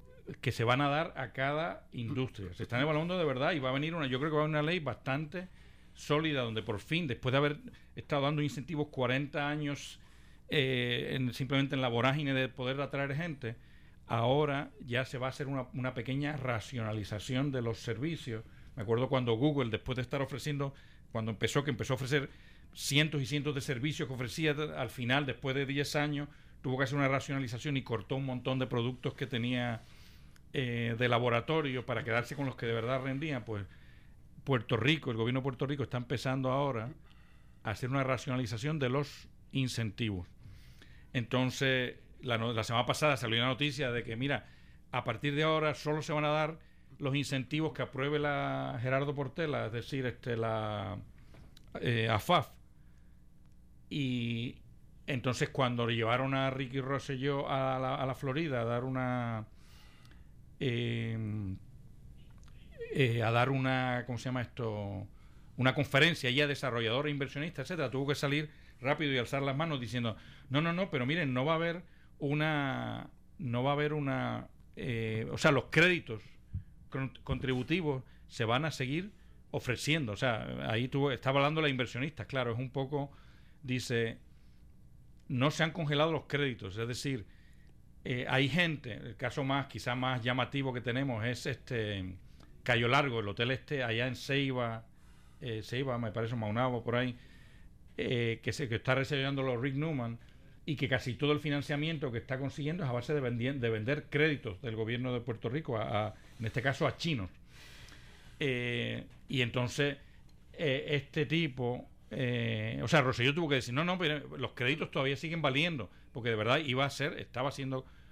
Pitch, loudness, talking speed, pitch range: 130 Hz, -34 LUFS, 175 wpm, 120-145 Hz